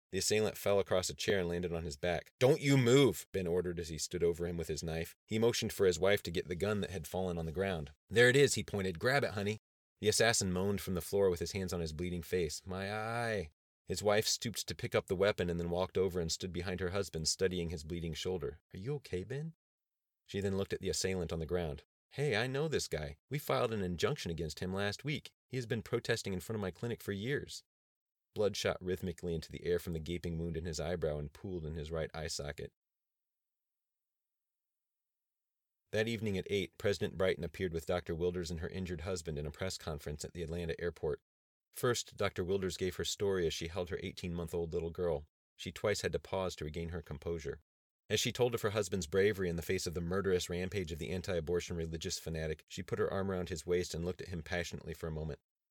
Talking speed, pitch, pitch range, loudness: 240 wpm, 90 Hz, 85-100 Hz, -36 LUFS